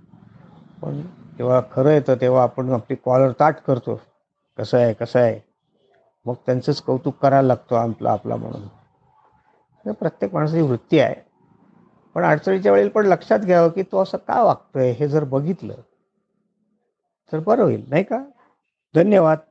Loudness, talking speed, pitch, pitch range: -19 LUFS, 145 wpm, 140 Hz, 125-180 Hz